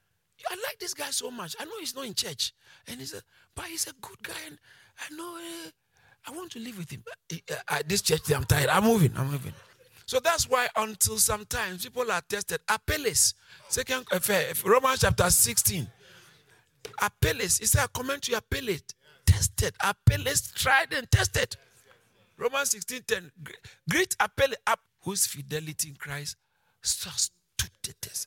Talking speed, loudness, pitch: 170 wpm, -27 LUFS, 220 Hz